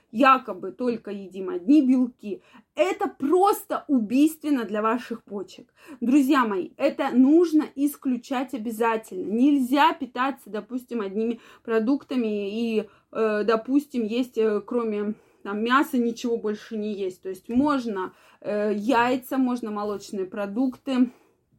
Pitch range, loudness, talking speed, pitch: 215-275 Hz, -24 LUFS, 110 wpm, 240 Hz